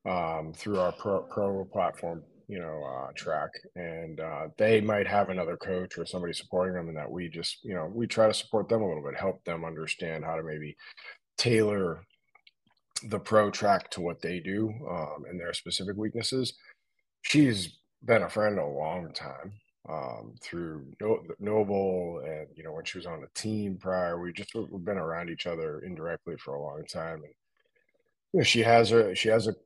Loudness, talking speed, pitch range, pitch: -30 LUFS, 190 wpm, 85-110 Hz, 95 Hz